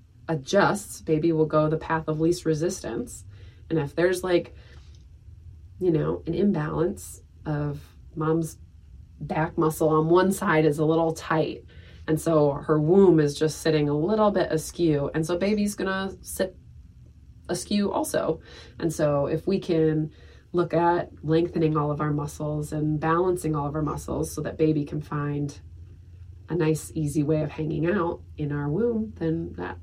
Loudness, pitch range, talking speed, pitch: -25 LUFS, 145-165 Hz, 165 wpm, 155 Hz